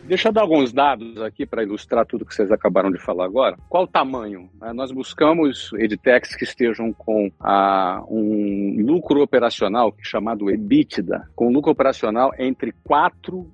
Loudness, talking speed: -20 LUFS, 160 wpm